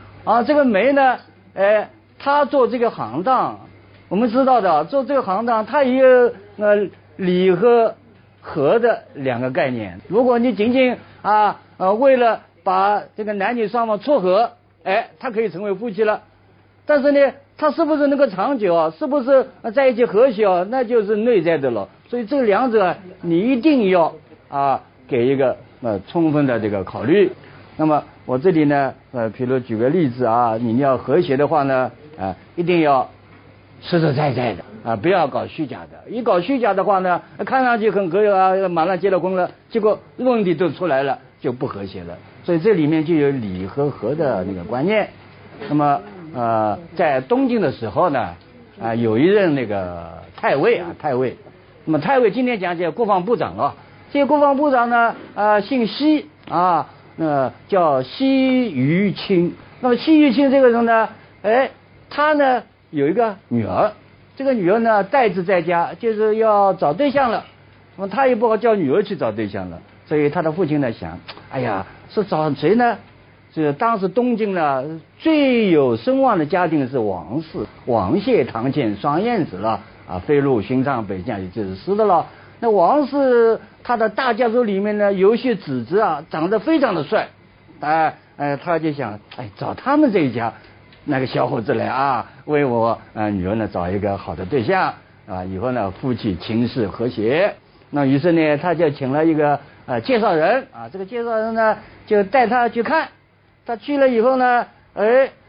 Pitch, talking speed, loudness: 180 Hz, 255 characters per minute, -18 LUFS